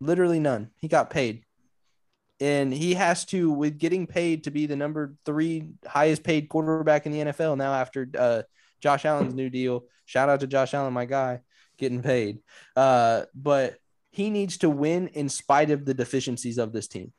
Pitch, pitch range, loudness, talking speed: 145 Hz, 130-155 Hz, -25 LUFS, 185 wpm